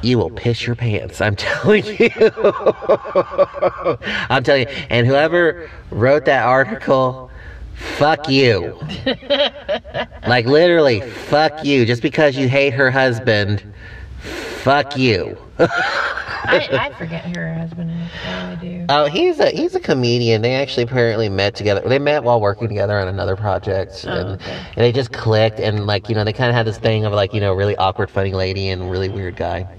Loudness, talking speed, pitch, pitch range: -17 LUFS, 160 wpm, 120 Hz, 100-145 Hz